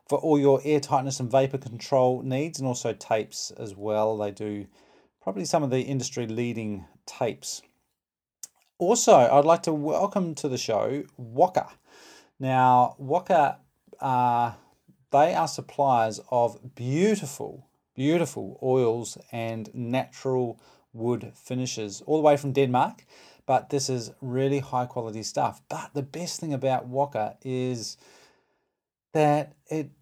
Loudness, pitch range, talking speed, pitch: -26 LUFS, 120-145 Hz, 135 wpm, 130 Hz